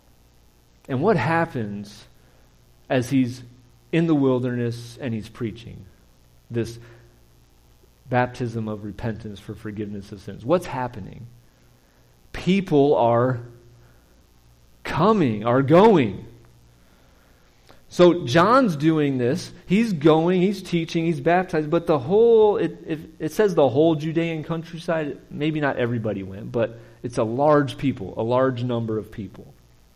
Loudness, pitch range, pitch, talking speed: -22 LUFS, 95-160 Hz, 120 Hz, 120 wpm